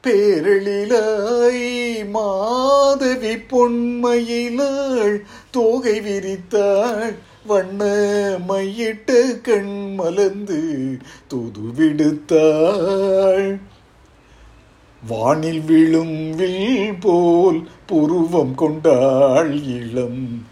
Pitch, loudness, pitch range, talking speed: 200 Hz, -18 LUFS, 160-235 Hz, 50 wpm